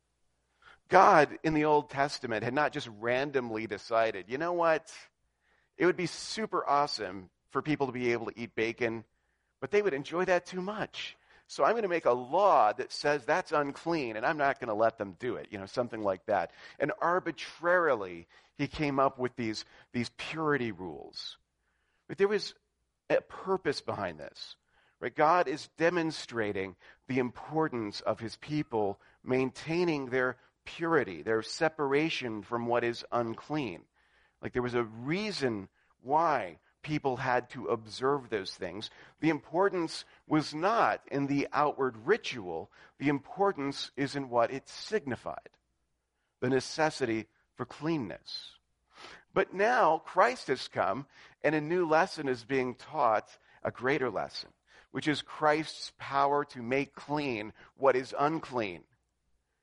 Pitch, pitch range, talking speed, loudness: 135 Hz, 115-155 Hz, 150 wpm, -31 LUFS